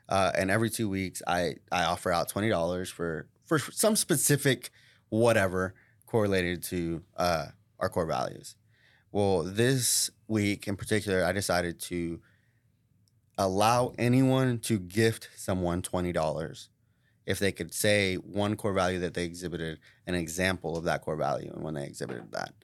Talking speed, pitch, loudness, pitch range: 155 wpm, 100 Hz, -29 LUFS, 90-115 Hz